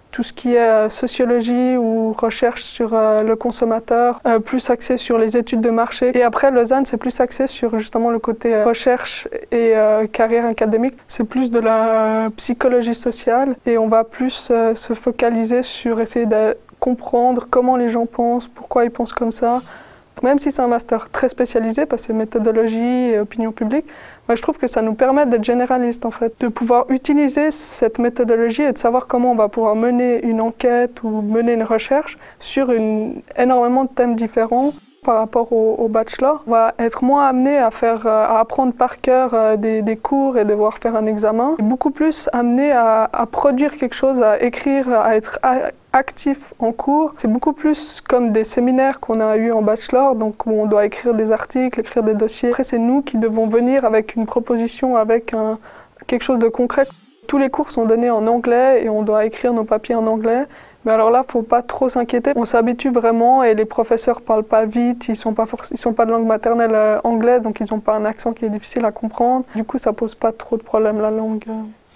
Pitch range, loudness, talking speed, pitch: 225-255 Hz, -17 LUFS, 205 wpm, 235 Hz